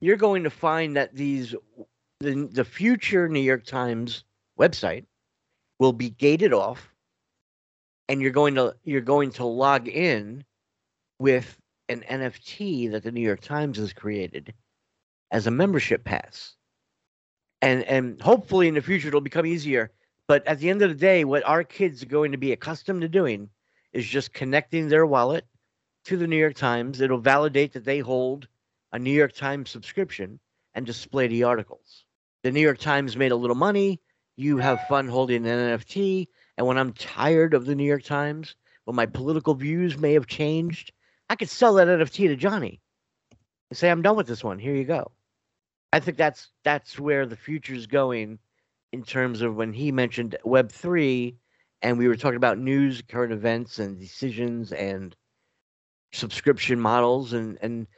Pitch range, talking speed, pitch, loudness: 120-150 Hz, 175 wpm, 130 Hz, -24 LUFS